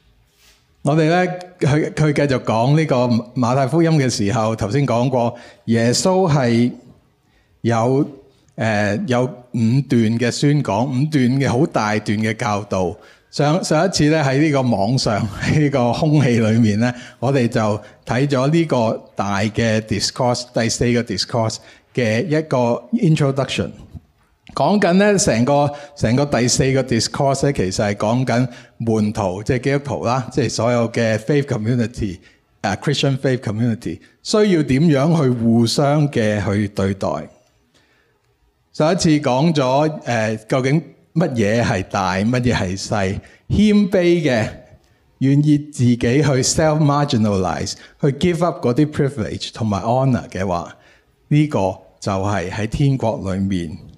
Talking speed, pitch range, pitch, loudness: 295 characters per minute, 110-145 Hz, 125 Hz, -18 LUFS